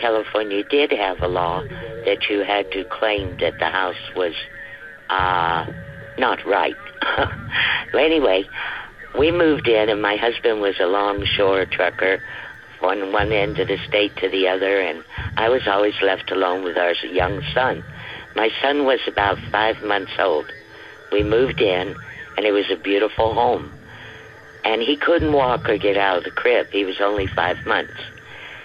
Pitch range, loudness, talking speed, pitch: 95-110 Hz, -20 LUFS, 165 wpm, 100 Hz